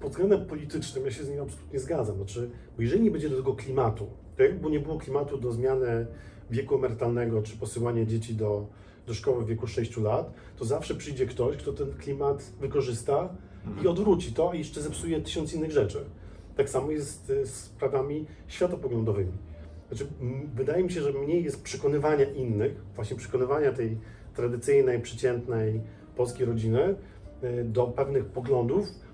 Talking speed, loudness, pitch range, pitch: 165 wpm, -29 LUFS, 110-145 Hz, 125 Hz